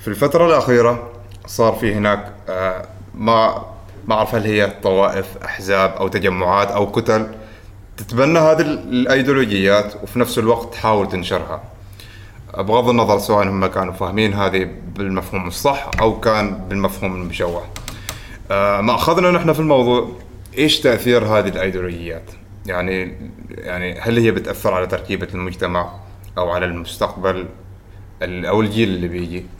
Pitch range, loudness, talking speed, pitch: 95-115 Hz, -17 LUFS, 125 wpm, 100 Hz